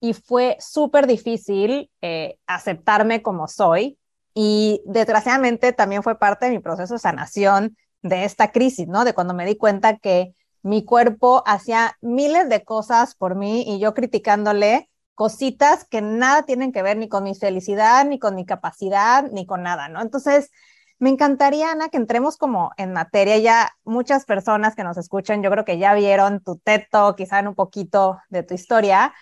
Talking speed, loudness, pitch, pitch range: 175 wpm, -19 LUFS, 215 Hz, 200-245 Hz